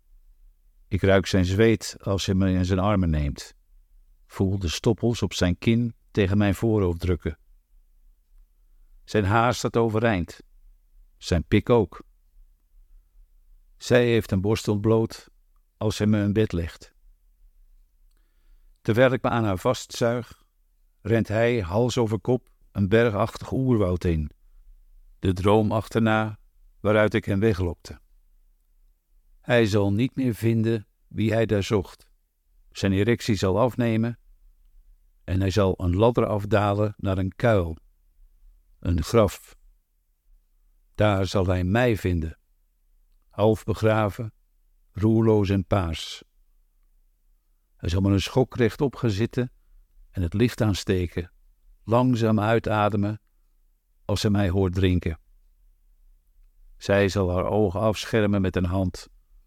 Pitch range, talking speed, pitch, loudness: 75-110 Hz, 120 wpm, 95 Hz, -24 LUFS